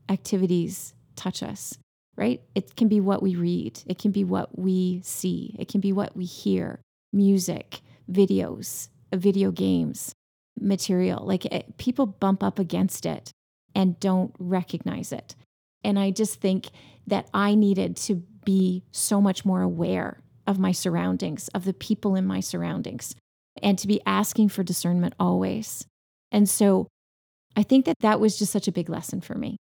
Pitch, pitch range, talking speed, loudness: 190 Hz, 180-205 Hz, 165 wpm, -25 LUFS